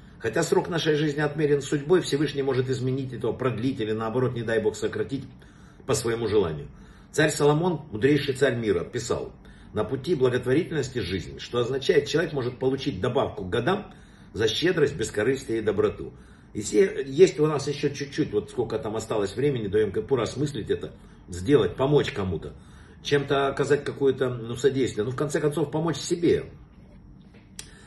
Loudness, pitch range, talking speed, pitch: -25 LUFS, 130-155 Hz, 160 wpm, 140 Hz